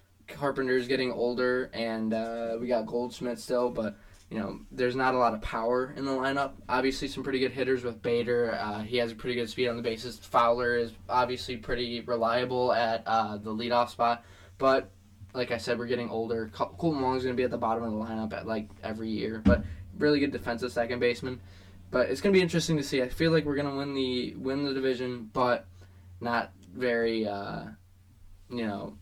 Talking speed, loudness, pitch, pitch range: 210 wpm, -29 LUFS, 120 Hz, 110-125 Hz